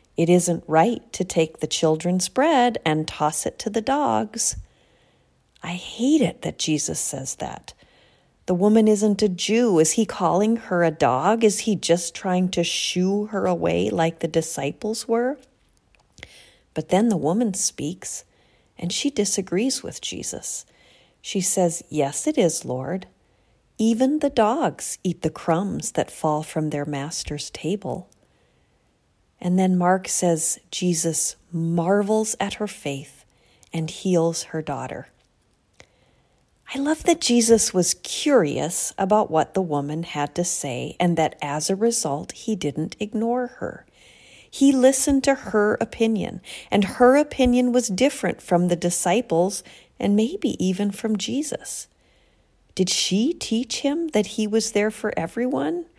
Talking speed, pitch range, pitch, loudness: 145 wpm, 165-230 Hz, 190 Hz, -22 LUFS